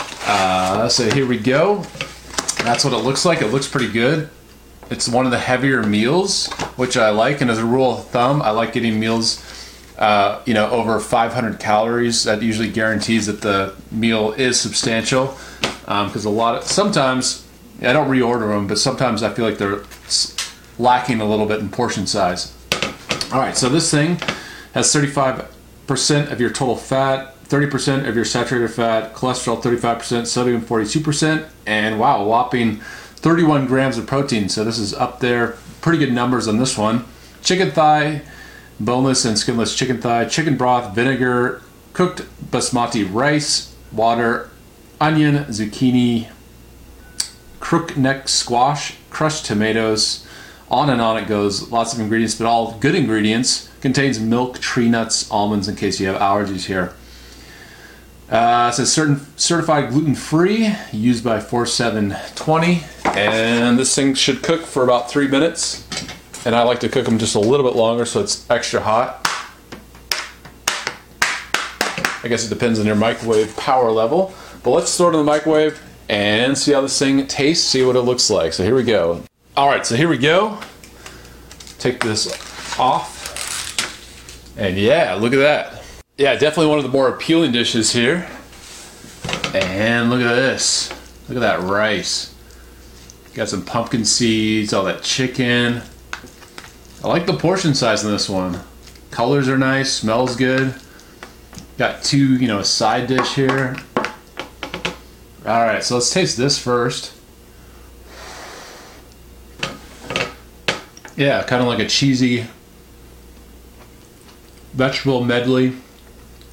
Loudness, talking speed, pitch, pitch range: -18 LUFS, 150 wpm, 120 Hz, 110-135 Hz